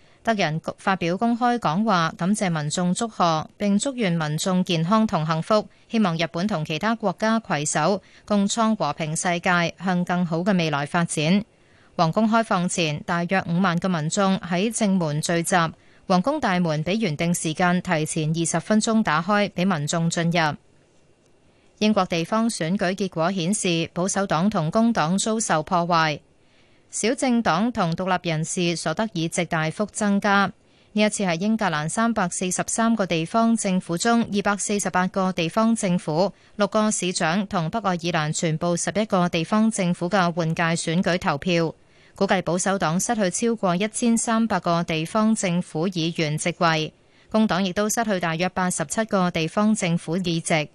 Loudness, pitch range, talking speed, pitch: -23 LUFS, 165-210 Hz, 255 characters per minute, 180 Hz